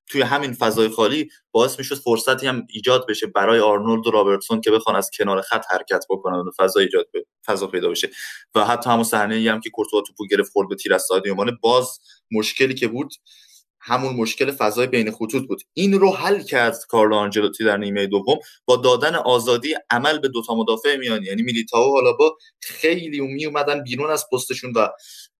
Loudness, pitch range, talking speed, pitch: -20 LUFS, 110-155 Hz, 190 wpm, 125 Hz